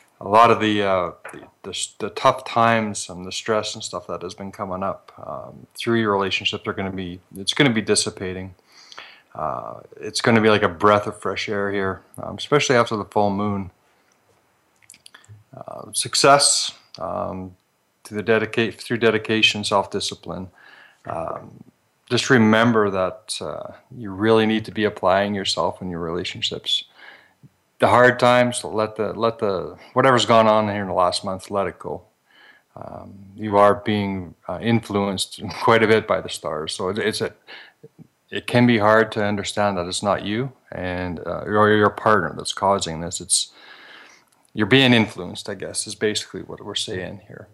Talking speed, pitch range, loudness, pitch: 175 wpm, 95-110 Hz, -20 LUFS, 105 Hz